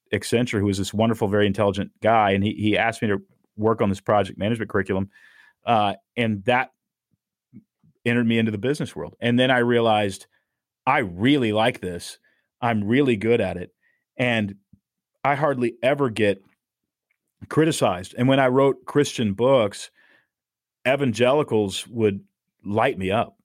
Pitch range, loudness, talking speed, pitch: 100-125 Hz, -22 LUFS, 150 wpm, 110 Hz